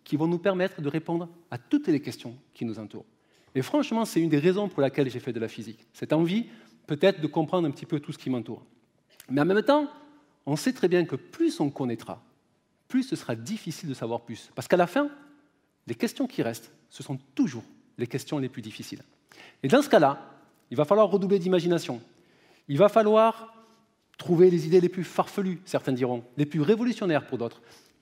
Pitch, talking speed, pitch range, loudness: 155 Hz, 210 wpm, 130-200 Hz, -26 LUFS